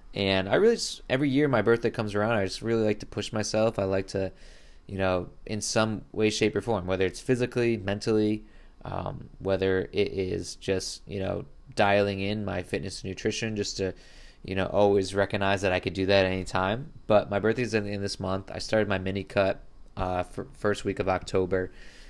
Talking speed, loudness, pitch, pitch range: 210 wpm, -28 LUFS, 100 Hz, 95-110 Hz